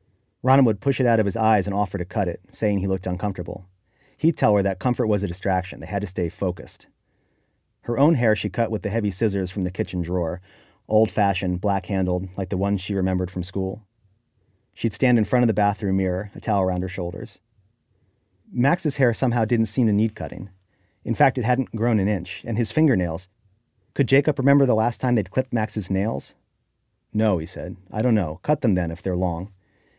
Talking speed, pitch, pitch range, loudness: 210 wpm, 105 Hz, 95-115 Hz, -23 LUFS